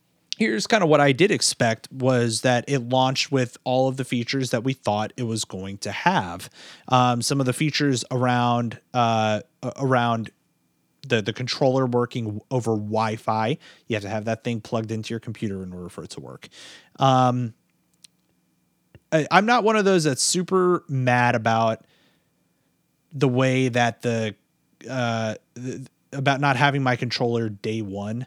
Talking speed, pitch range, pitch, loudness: 165 wpm, 115-135 Hz, 125 Hz, -22 LUFS